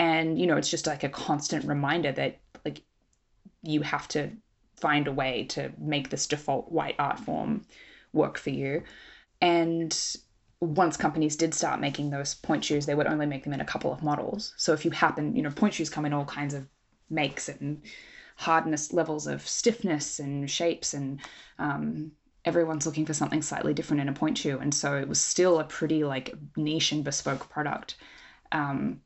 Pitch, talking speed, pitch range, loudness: 150 Hz, 190 wpm, 140-160 Hz, -29 LUFS